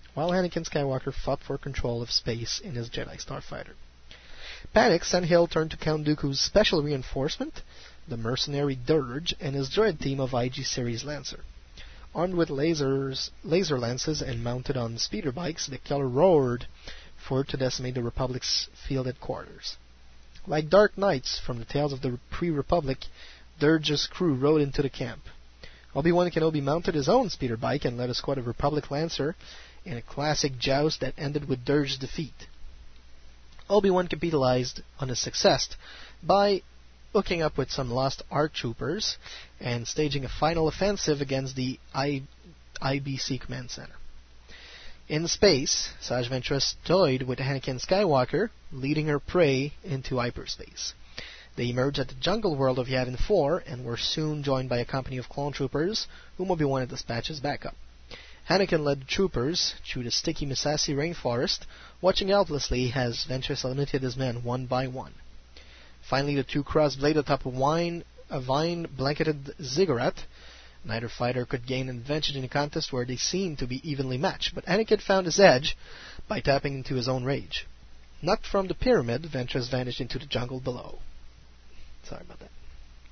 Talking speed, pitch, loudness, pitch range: 160 wpm, 135 Hz, -27 LUFS, 120-150 Hz